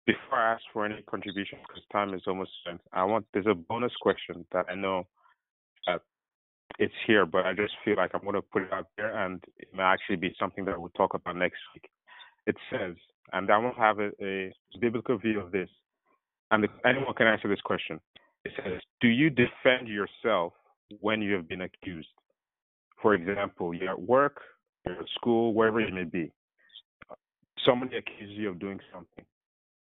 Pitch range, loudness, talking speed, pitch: 95-110 Hz, -29 LUFS, 190 wpm, 105 Hz